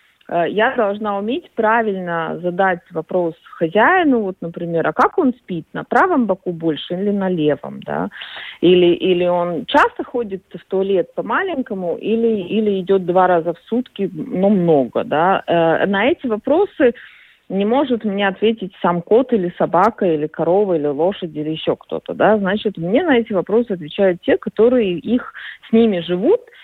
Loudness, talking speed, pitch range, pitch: -17 LUFS, 160 wpm, 175-230 Hz, 195 Hz